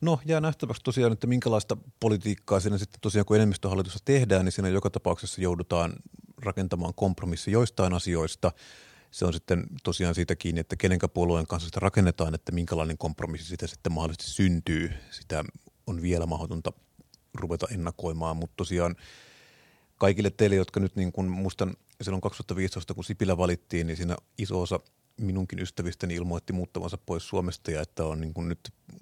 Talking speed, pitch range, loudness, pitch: 155 wpm, 85-100 Hz, -29 LUFS, 90 Hz